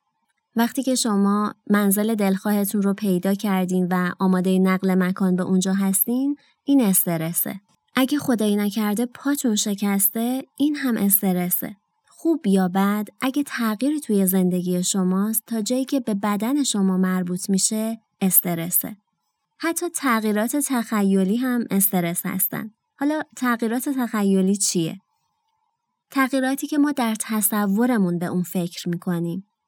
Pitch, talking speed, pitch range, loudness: 210 Hz, 125 wpm, 190-250 Hz, -21 LUFS